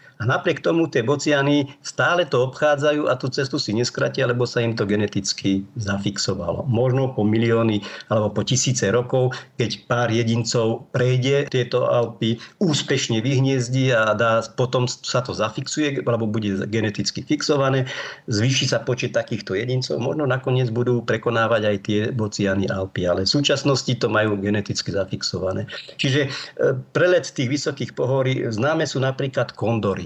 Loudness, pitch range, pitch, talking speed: -21 LUFS, 110-135 Hz, 125 Hz, 145 wpm